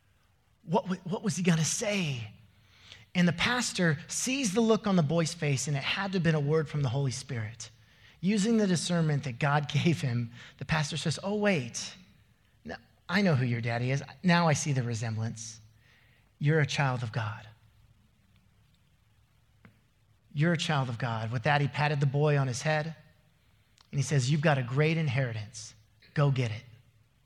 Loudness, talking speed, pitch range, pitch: -29 LUFS, 185 wpm, 115-160 Hz, 140 Hz